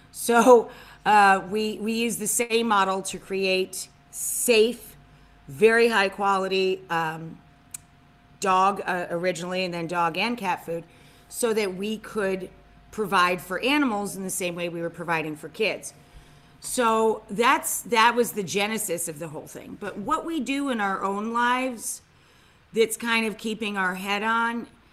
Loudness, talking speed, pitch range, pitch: -24 LUFS, 155 wpm, 175-225 Hz, 195 Hz